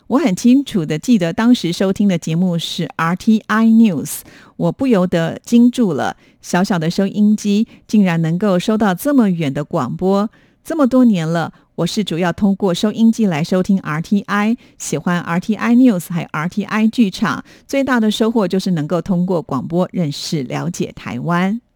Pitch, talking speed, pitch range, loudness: 195 Hz, 280 characters per minute, 170-225 Hz, -16 LUFS